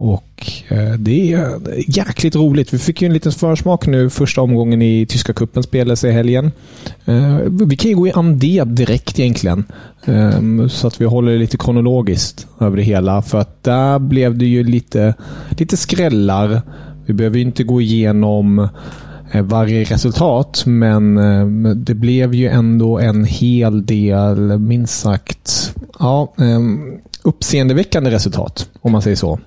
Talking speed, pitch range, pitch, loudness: 145 wpm, 105-130 Hz, 120 Hz, -14 LUFS